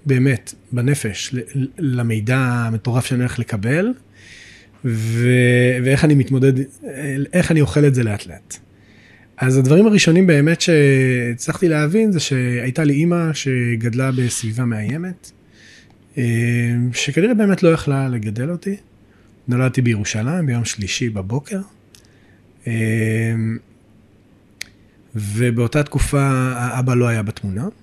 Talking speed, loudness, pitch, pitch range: 105 wpm, -18 LUFS, 125 Hz, 110-140 Hz